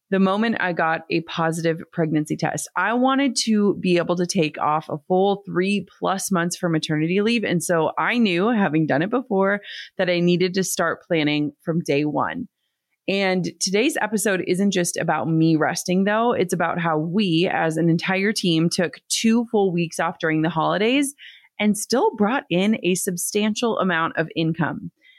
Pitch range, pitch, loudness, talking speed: 165-205 Hz, 180 Hz, -21 LUFS, 180 wpm